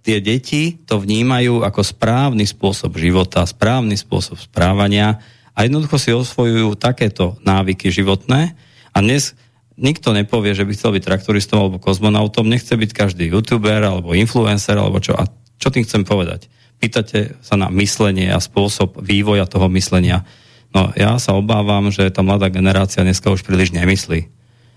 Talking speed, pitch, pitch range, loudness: 155 wpm, 105 Hz, 95-120 Hz, -16 LUFS